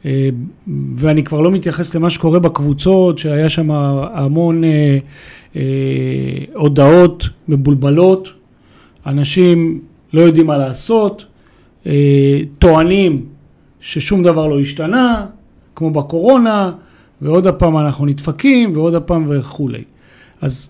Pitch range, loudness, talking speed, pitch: 140-175 Hz, -13 LUFS, 95 wpm, 155 Hz